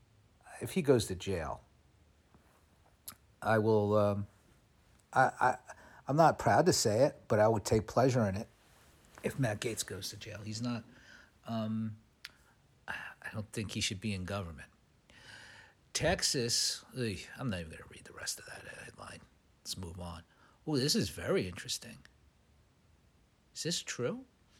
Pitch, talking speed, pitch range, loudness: 105 Hz, 155 wpm, 95-115 Hz, -33 LUFS